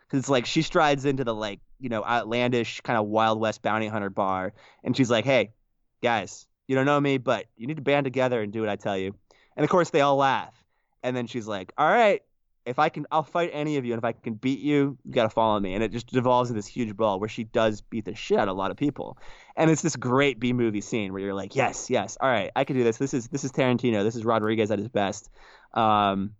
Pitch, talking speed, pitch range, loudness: 120 Hz, 275 wpm, 110-140 Hz, -25 LUFS